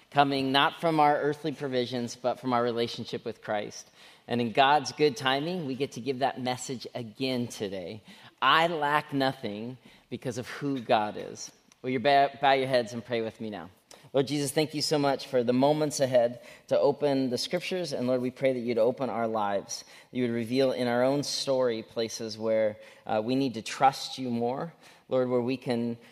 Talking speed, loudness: 200 wpm, -28 LUFS